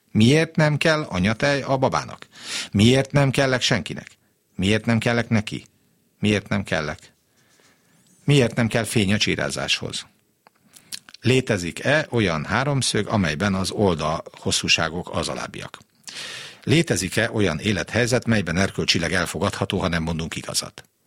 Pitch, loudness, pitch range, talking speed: 110 Hz, -21 LUFS, 95-125 Hz, 120 wpm